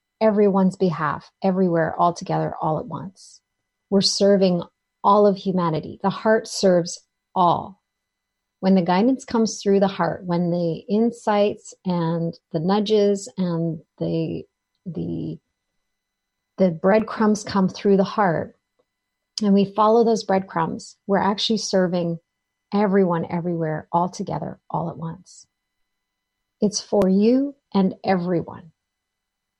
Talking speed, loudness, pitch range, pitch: 120 wpm, -21 LUFS, 160-205 Hz, 185 Hz